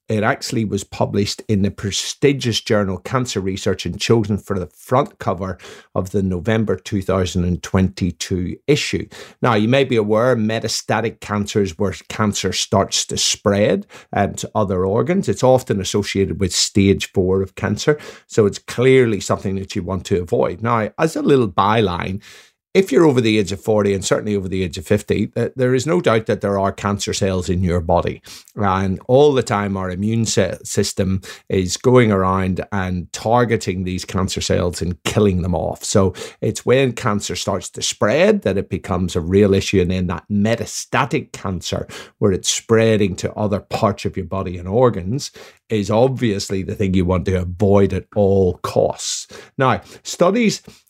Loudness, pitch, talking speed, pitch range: -18 LUFS, 100 Hz, 175 wpm, 95-110 Hz